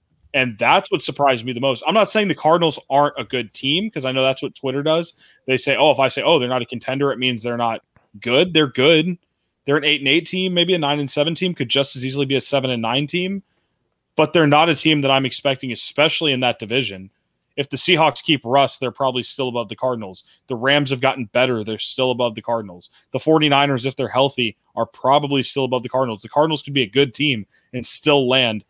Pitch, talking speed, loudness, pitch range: 135 Hz, 245 wpm, -18 LUFS, 125-150 Hz